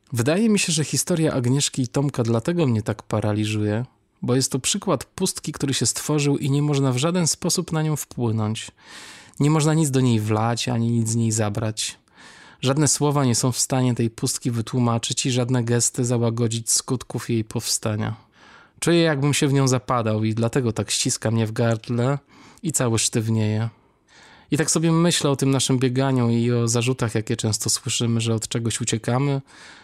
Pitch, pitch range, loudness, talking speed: 125 Hz, 115-140 Hz, -22 LUFS, 180 wpm